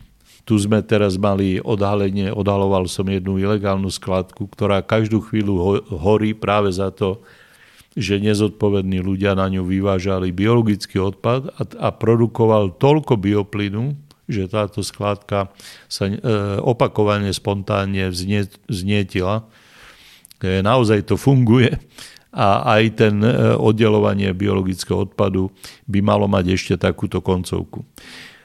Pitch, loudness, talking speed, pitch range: 100 Hz, -19 LUFS, 110 wpm, 95-110 Hz